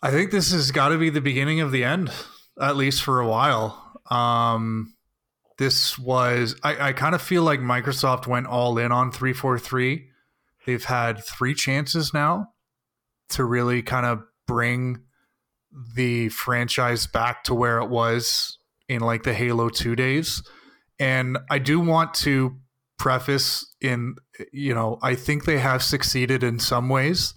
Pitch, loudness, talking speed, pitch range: 130 Hz, -22 LUFS, 160 wpm, 120-140 Hz